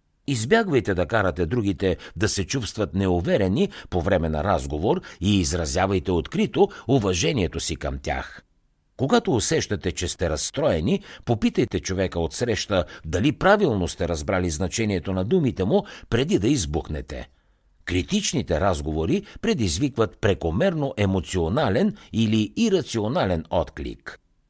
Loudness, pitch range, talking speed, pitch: -23 LUFS, 85-115 Hz, 115 wpm, 95 Hz